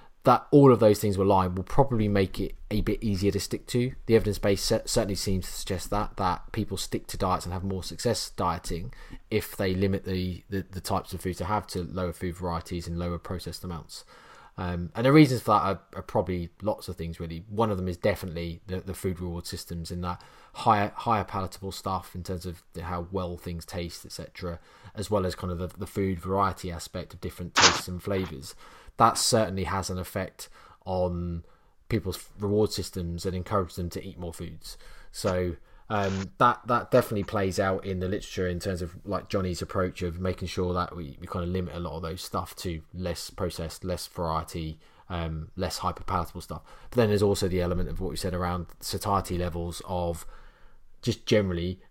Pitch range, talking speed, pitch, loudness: 85-100 Hz, 205 wpm, 95 Hz, -28 LUFS